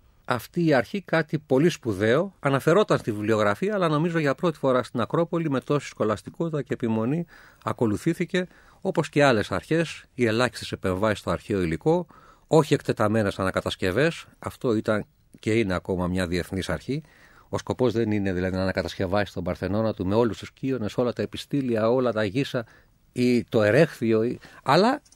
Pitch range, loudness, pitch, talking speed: 105-145 Hz, -25 LUFS, 120 Hz, 160 wpm